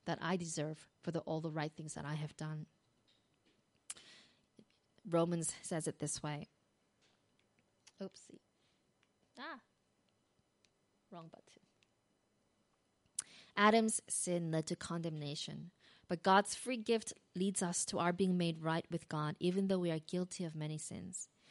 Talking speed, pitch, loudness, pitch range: 135 wpm, 170 Hz, -38 LUFS, 155-185 Hz